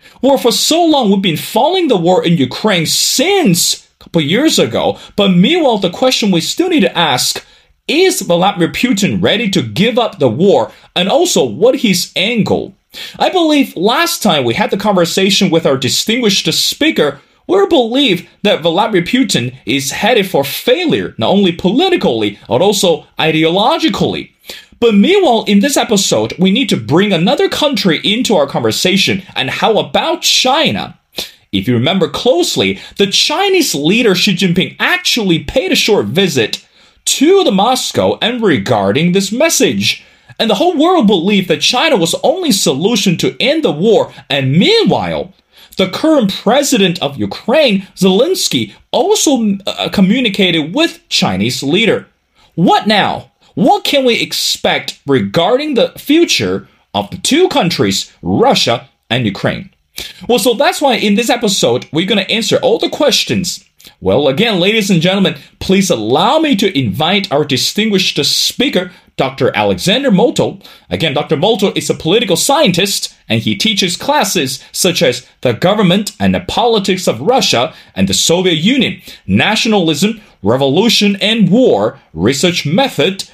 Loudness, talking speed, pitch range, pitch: -12 LUFS, 150 wpm, 170-245 Hz, 195 Hz